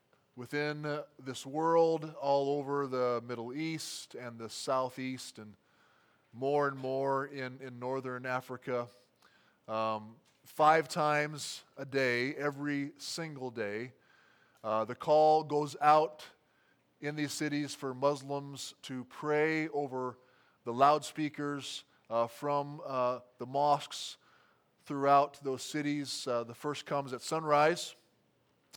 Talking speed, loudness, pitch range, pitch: 115 wpm, -33 LUFS, 125-150 Hz, 140 Hz